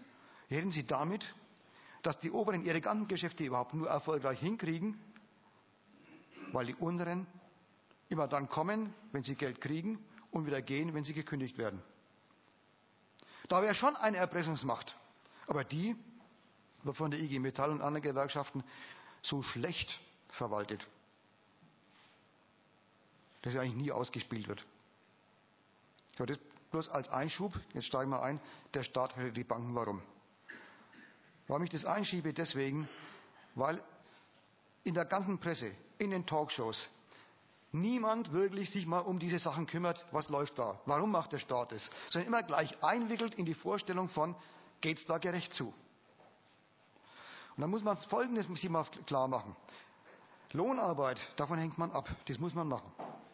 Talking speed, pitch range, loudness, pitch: 140 wpm, 135-185 Hz, -38 LUFS, 160 Hz